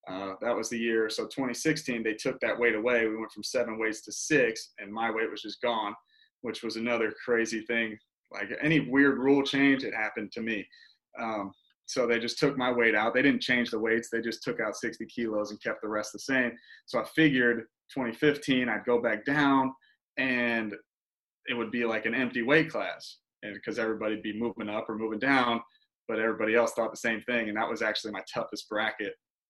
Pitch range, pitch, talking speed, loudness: 110-135 Hz, 120 Hz, 210 wpm, -29 LUFS